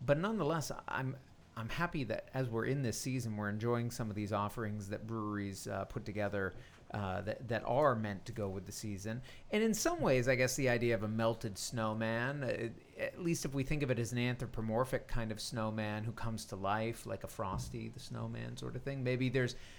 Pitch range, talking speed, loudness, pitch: 105-130 Hz, 220 wpm, -37 LUFS, 115 Hz